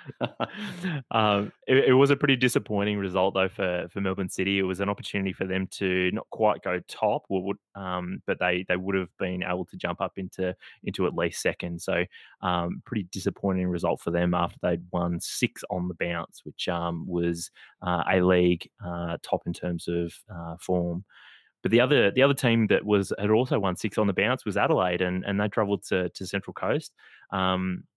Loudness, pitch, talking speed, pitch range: -27 LUFS, 95 Hz, 200 wpm, 90-100 Hz